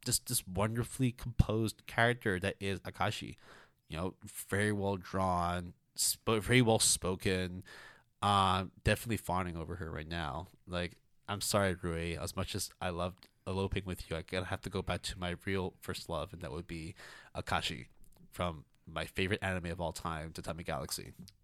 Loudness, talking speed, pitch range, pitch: -35 LUFS, 175 wpm, 85-100 Hz, 95 Hz